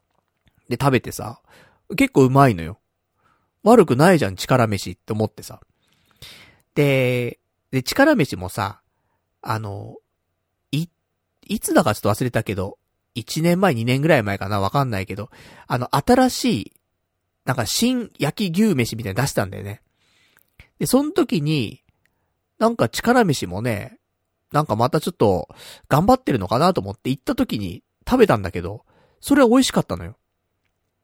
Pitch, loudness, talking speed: 115 Hz, -20 LUFS, 280 characters per minute